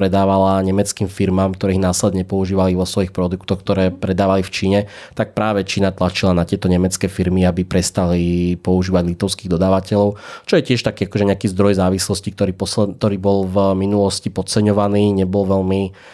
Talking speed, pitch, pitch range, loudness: 160 wpm, 95 Hz, 95-100 Hz, -17 LUFS